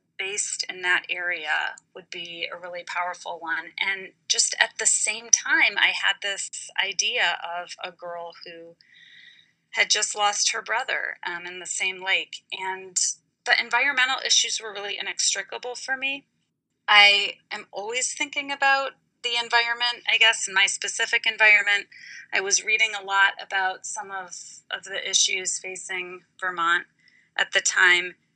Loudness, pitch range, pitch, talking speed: -22 LUFS, 180-235 Hz, 200 Hz, 150 wpm